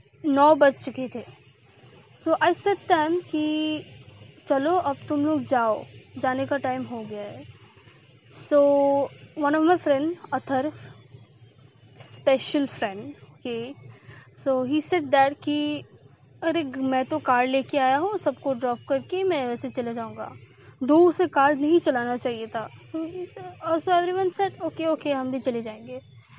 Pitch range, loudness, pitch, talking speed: 225-310 Hz, -24 LUFS, 275 Hz, 145 wpm